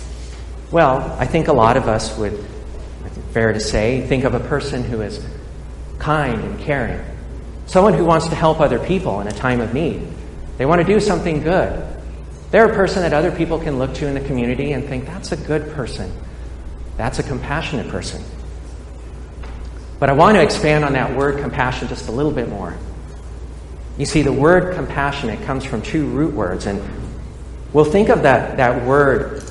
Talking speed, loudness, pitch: 185 wpm, -17 LUFS, 125 Hz